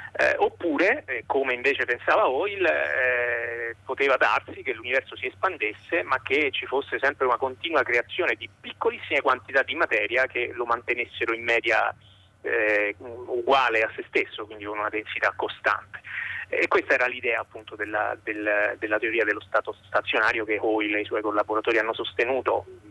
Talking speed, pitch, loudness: 165 wpm, 120 Hz, -25 LUFS